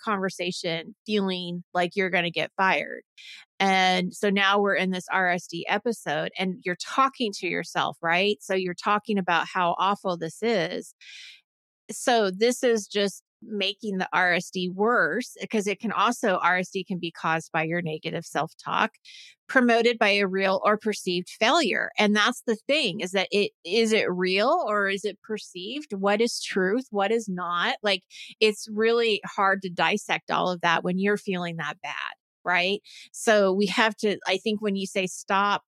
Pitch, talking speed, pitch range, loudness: 195 Hz, 175 wpm, 180-215 Hz, -25 LUFS